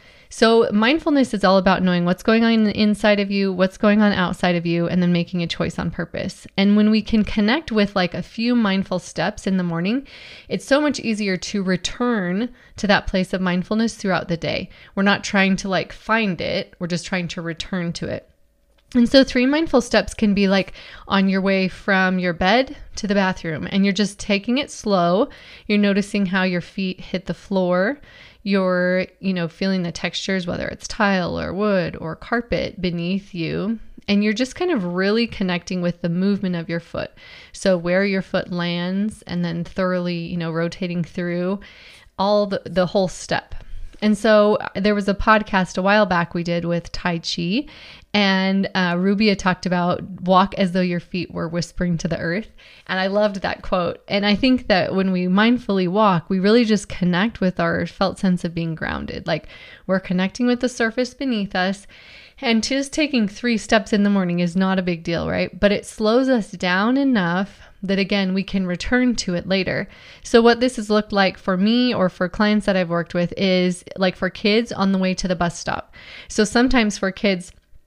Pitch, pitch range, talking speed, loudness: 195 Hz, 180-215 Hz, 200 wpm, -20 LUFS